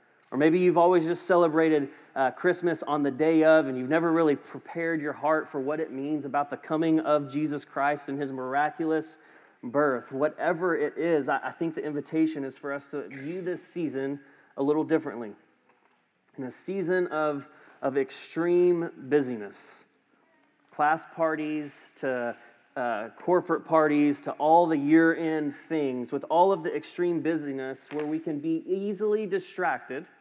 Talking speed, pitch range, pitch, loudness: 165 wpm, 140-165 Hz, 155 Hz, -27 LUFS